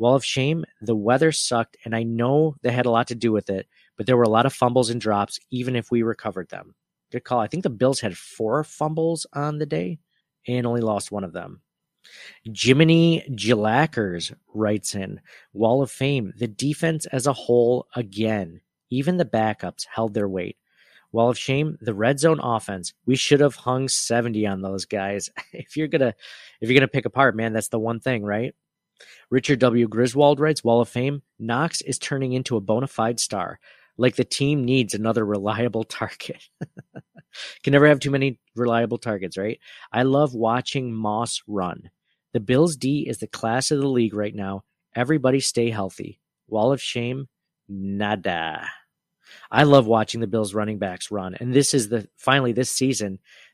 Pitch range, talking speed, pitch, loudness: 110-135 Hz, 185 wpm, 120 Hz, -22 LUFS